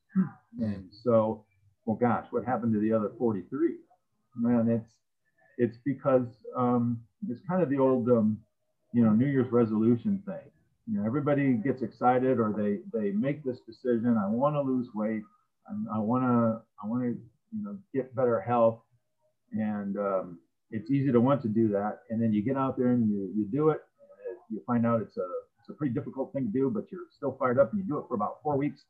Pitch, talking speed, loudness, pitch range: 120 Hz, 205 wpm, -29 LUFS, 110-145 Hz